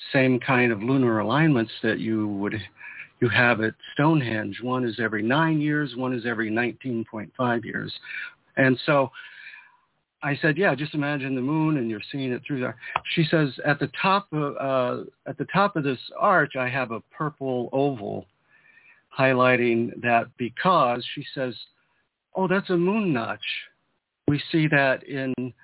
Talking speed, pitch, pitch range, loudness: 160 wpm, 130 Hz, 120-150 Hz, -24 LUFS